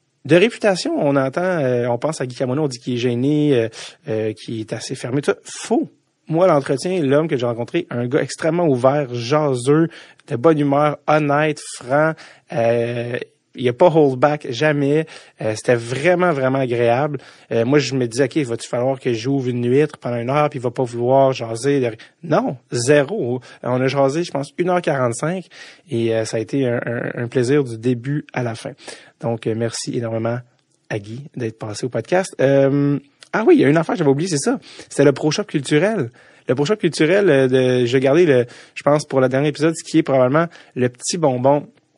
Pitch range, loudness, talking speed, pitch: 125-150 Hz, -19 LUFS, 210 wpm, 135 Hz